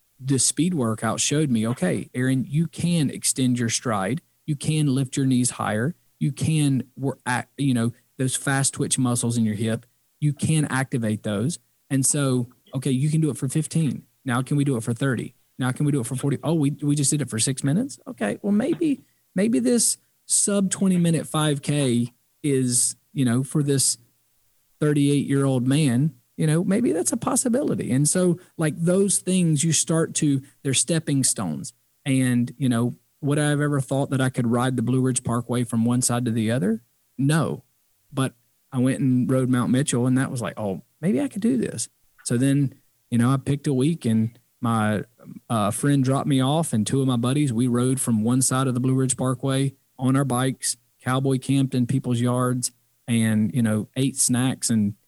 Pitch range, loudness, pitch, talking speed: 120-145 Hz, -23 LUFS, 130 Hz, 200 wpm